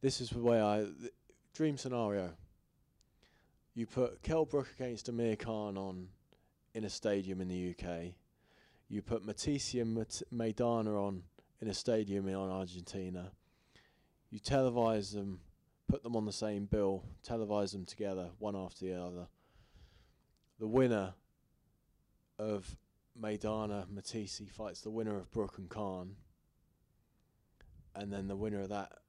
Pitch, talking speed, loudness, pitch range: 105 Hz, 140 wpm, -38 LUFS, 95-115 Hz